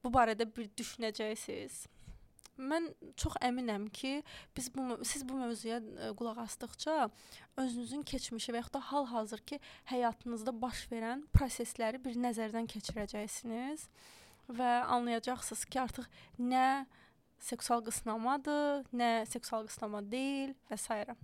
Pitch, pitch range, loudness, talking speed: 245 Hz, 225-265 Hz, -38 LUFS, 115 wpm